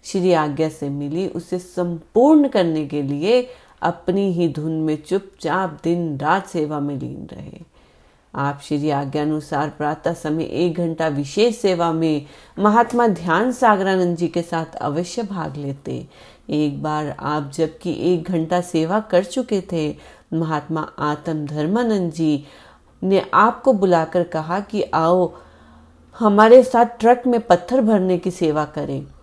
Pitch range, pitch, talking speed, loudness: 150-190 Hz, 170 Hz, 140 wpm, -19 LUFS